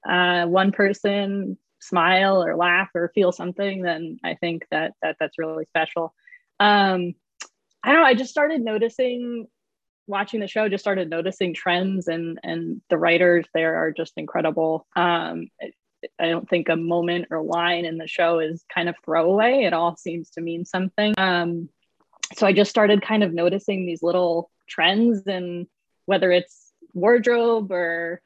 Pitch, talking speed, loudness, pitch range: 180 Hz, 165 wpm, -21 LUFS, 170-200 Hz